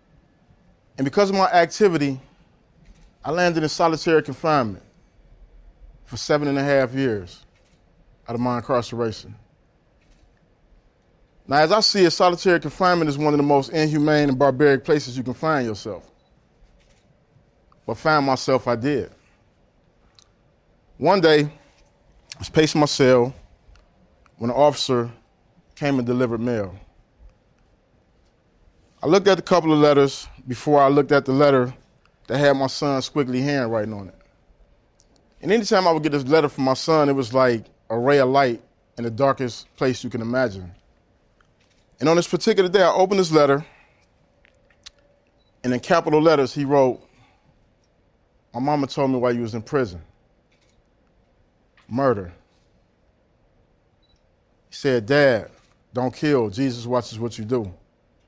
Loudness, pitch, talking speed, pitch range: -20 LUFS, 135 Hz, 145 wpm, 120-150 Hz